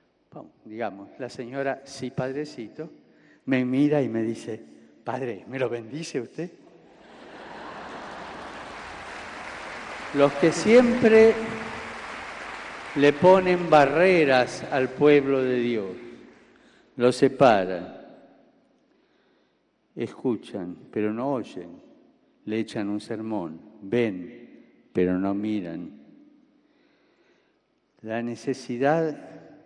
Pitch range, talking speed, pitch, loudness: 120-165 Hz, 85 wpm, 135 Hz, -24 LUFS